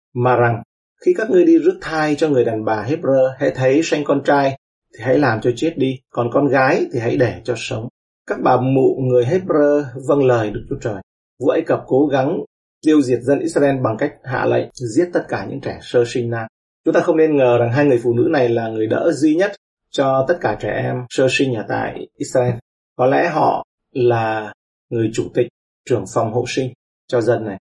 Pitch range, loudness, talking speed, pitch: 120-150 Hz, -18 LUFS, 225 wpm, 130 Hz